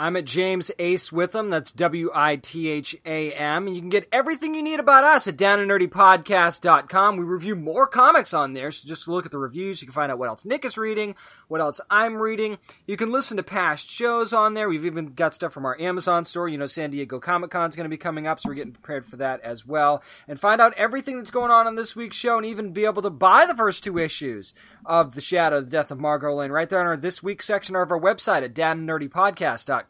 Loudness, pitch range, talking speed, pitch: -22 LUFS, 160-215 Hz, 255 wpm, 180 Hz